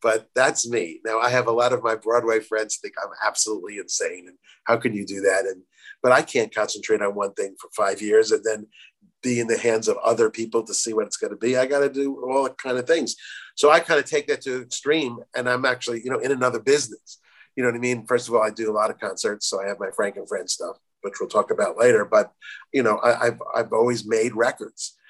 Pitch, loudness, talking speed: 135 Hz, -23 LUFS, 265 wpm